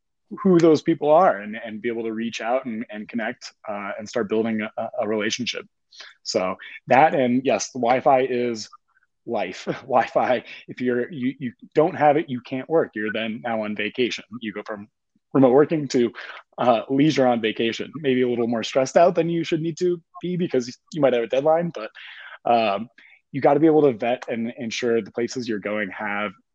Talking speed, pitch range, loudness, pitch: 200 wpm, 115-145 Hz, -22 LUFS, 125 Hz